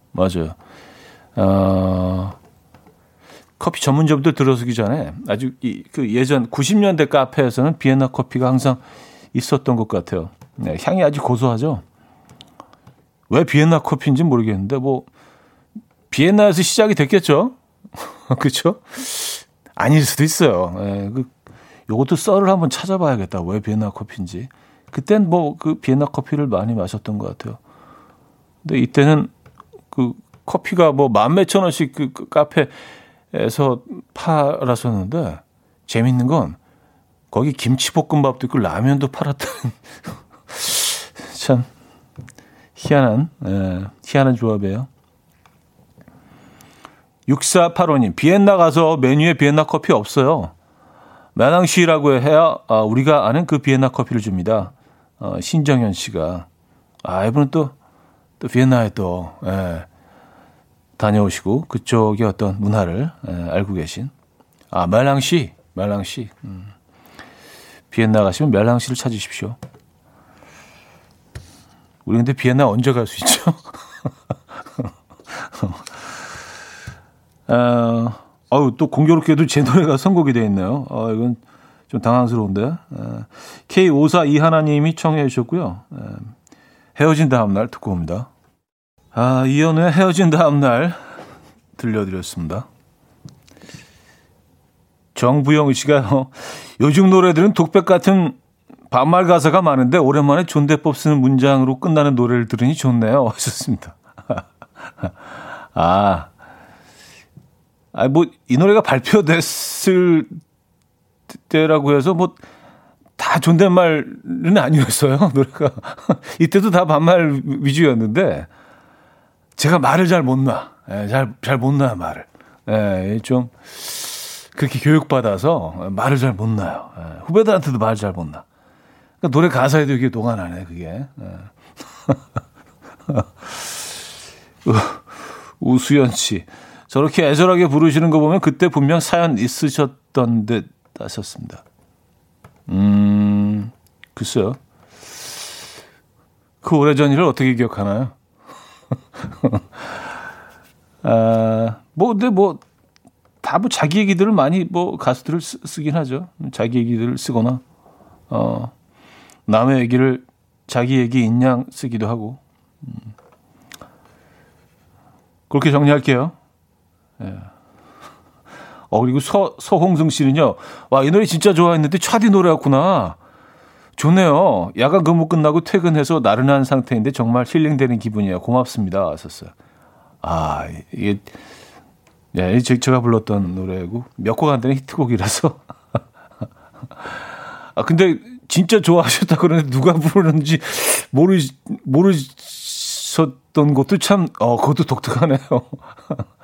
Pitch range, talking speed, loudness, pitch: 115-160 Hz, 235 characters per minute, -17 LUFS, 135 Hz